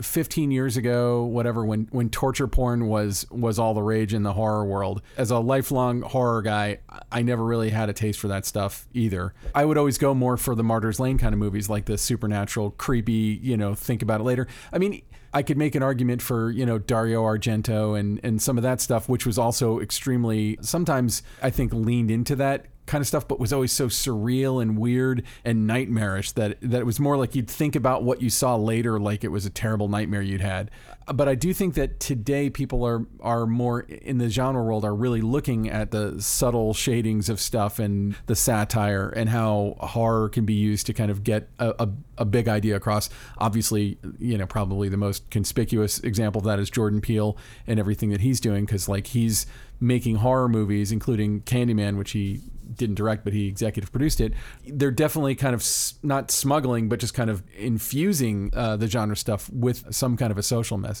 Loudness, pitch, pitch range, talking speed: -24 LUFS, 115 Hz, 105-125 Hz, 210 wpm